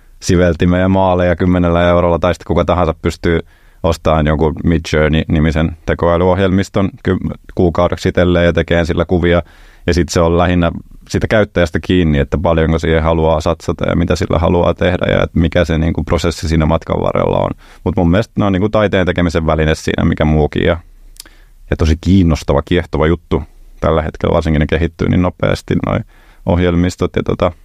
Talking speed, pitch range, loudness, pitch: 165 wpm, 80-90 Hz, -14 LUFS, 85 Hz